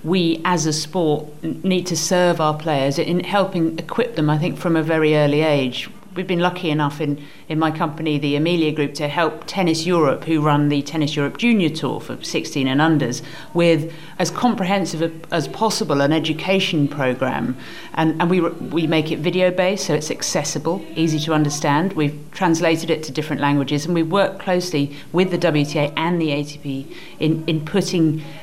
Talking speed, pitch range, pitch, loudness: 185 wpm, 150-175 Hz, 160 Hz, -20 LUFS